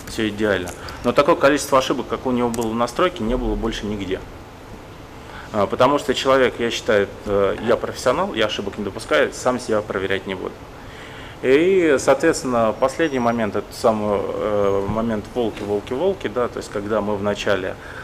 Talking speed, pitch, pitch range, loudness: 165 wpm, 115 Hz, 105-125 Hz, -20 LUFS